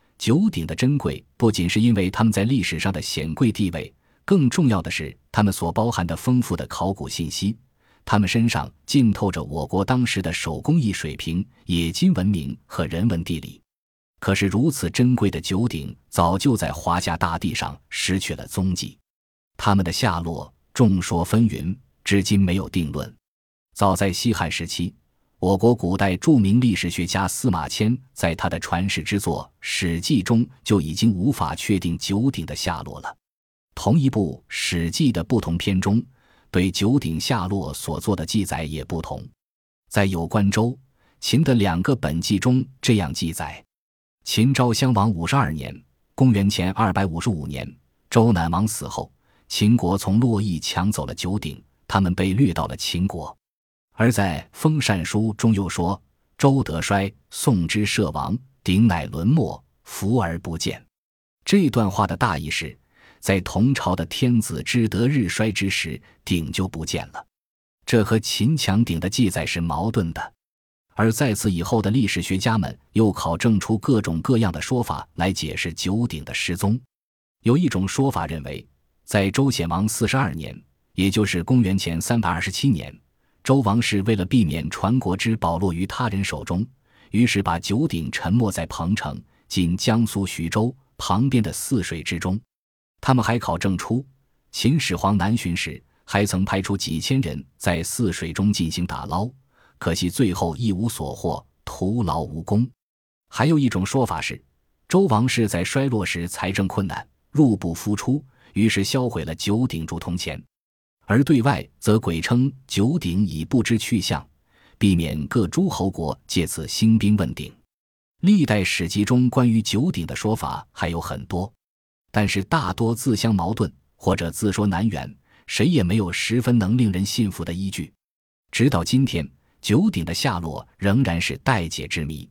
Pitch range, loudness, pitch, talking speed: 85-115 Hz, -22 LUFS, 100 Hz, 240 characters per minute